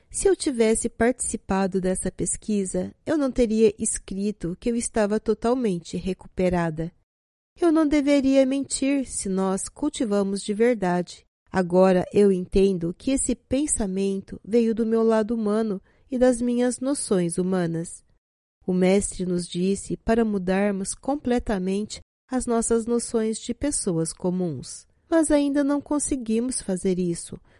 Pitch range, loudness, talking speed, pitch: 185-245 Hz, -24 LUFS, 130 wpm, 215 Hz